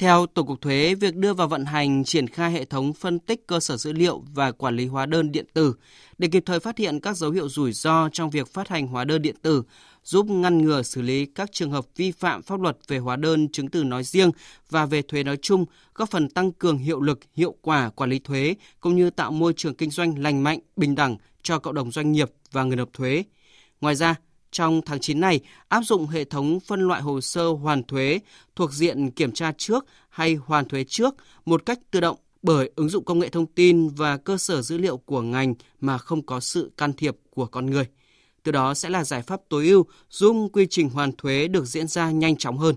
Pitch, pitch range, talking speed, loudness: 155 Hz, 140-175 Hz, 240 wpm, -23 LUFS